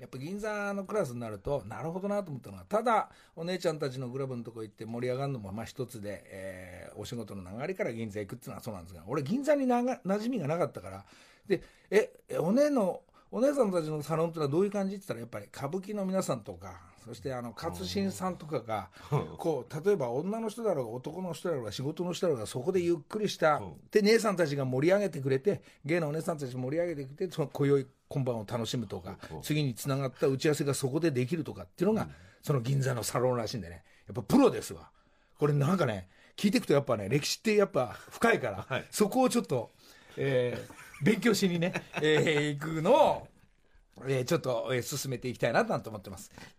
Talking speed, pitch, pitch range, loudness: 440 characters per minute, 145 Hz, 120-190 Hz, -31 LUFS